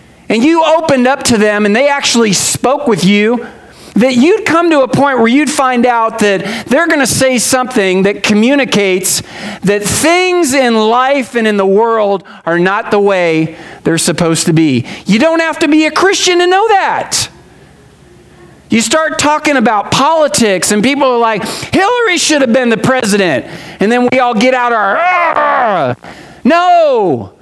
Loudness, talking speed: -10 LUFS, 175 wpm